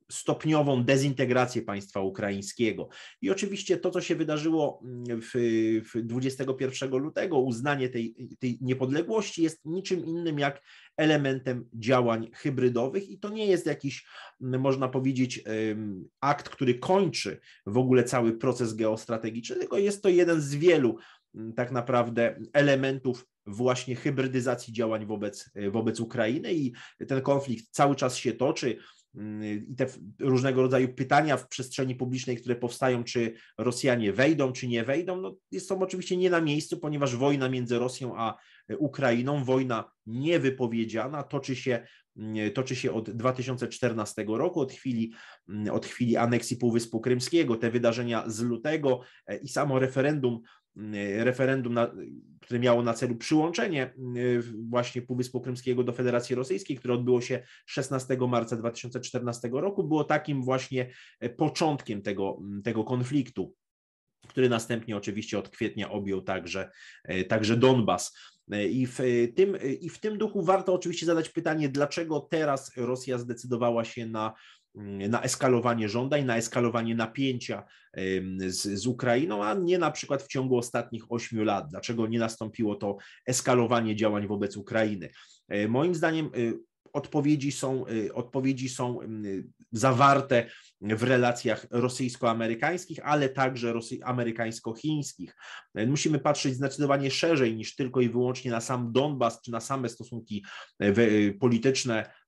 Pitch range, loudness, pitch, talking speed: 115-135 Hz, -28 LUFS, 125 Hz, 130 wpm